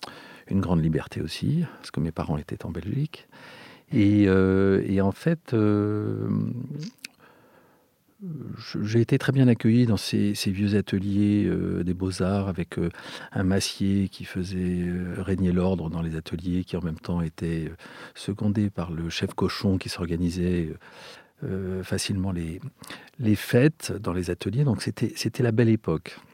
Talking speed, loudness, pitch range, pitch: 155 wpm, -26 LUFS, 90-110 Hz, 95 Hz